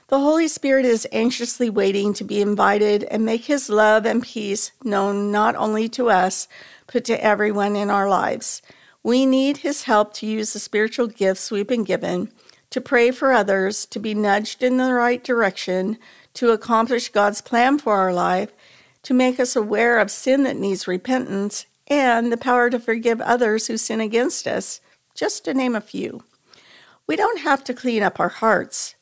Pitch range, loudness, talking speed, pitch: 205-250 Hz, -20 LUFS, 180 wpm, 225 Hz